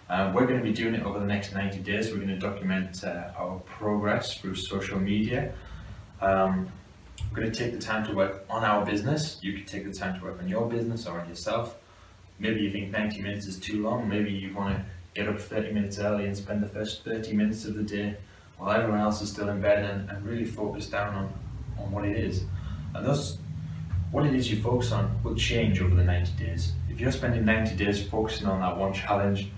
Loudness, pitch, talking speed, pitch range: -29 LUFS, 100 Hz, 230 wpm, 95-110 Hz